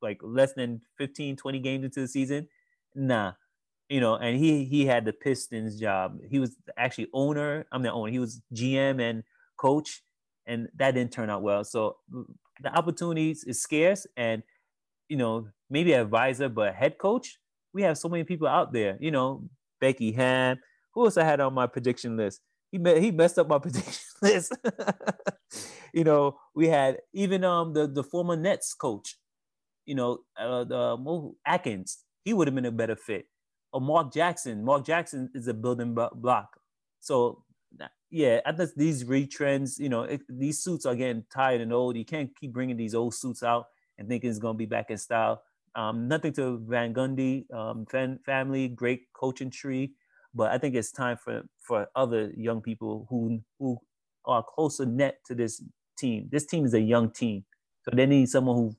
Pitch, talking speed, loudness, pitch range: 130 Hz, 185 wpm, -28 LUFS, 120-145 Hz